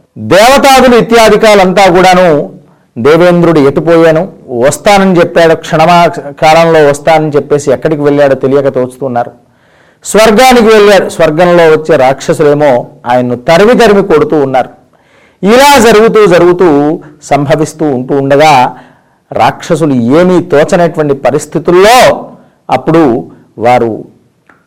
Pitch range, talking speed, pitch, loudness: 145-185 Hz, 90 wpm, 160 Hz, -5 LUFS